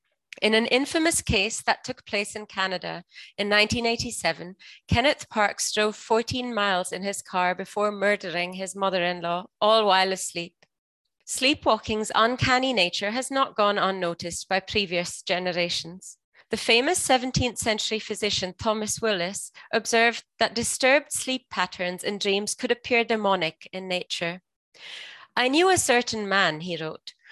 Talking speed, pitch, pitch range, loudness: 140 wpm, 205 Hz, 180-230 Hz, -24 LUFS